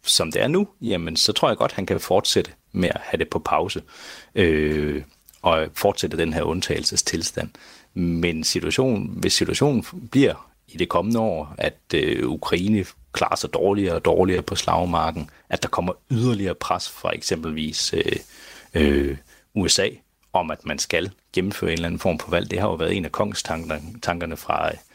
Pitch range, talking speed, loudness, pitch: 75-100 Hz, 175 wpm, -23 LUFS, 85 Hz